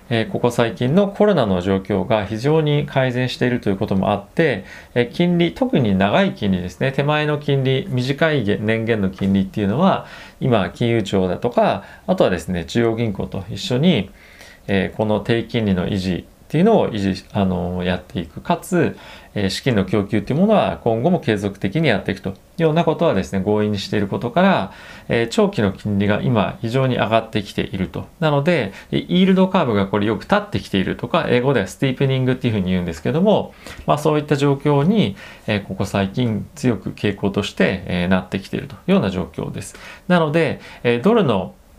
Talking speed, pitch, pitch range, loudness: 390 characters per minute, 110 Hz, 100-145 Hz, -19 LUFS